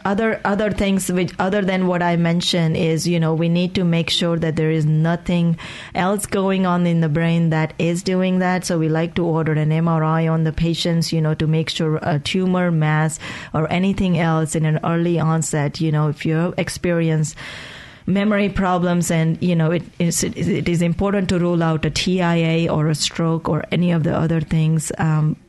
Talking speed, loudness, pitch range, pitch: 200 wpm, -19 LUFS, 160-180 Hz, 170 Hz